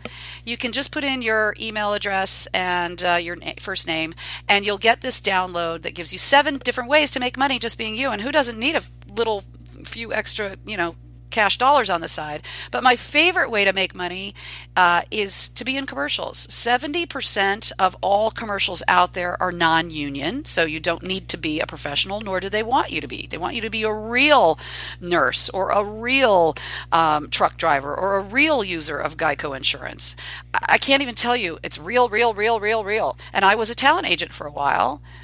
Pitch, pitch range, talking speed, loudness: 205 Hz, 170-245 Hz, 210 wpm, -19 LUFS